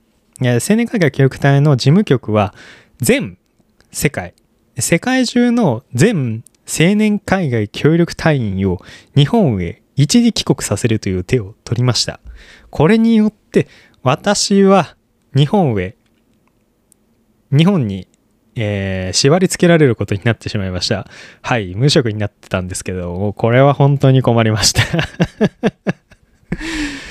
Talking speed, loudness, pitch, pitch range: 240 characters per minute, -15 LUFS, 125 Hz, 105-165 Hz